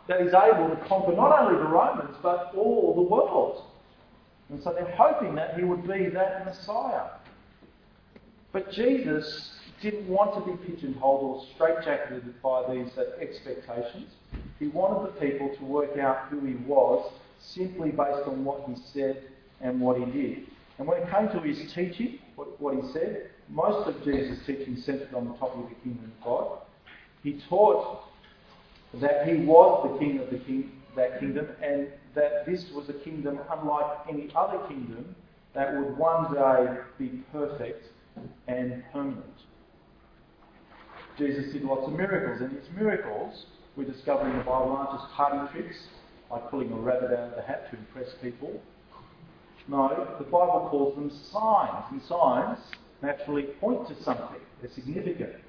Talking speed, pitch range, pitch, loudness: 160 wpm, 135-180 Hz, 145 Hz, -28 LUFS